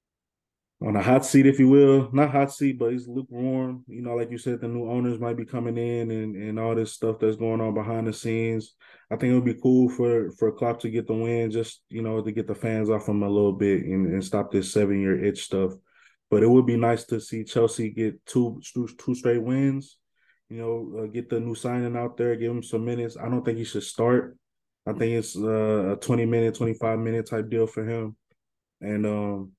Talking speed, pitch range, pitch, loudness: 235 wpm, 110-120 Hz, 115 Hz, -25 LUFS